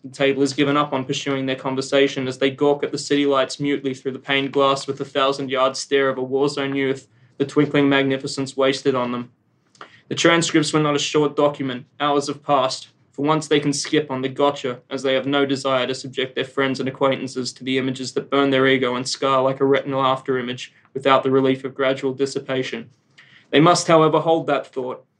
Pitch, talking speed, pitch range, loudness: 135 Hz, 220 wpm, 130-145 Hz, -20 LUFS